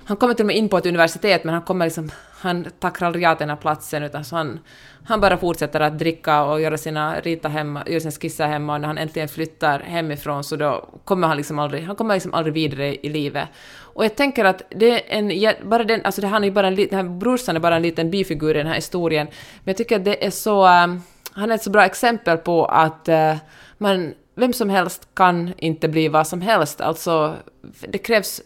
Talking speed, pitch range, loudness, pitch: 225 wpm, 155-195 Hz, -20 LUFS, 170 Hz